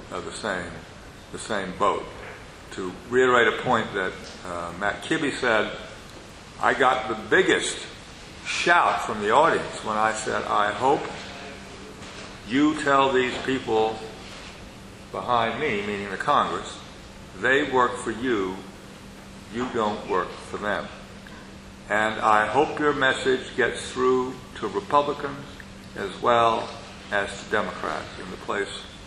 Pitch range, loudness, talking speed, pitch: 105-130 Hz, -24 LUFS, 130 wpm, 115 Hz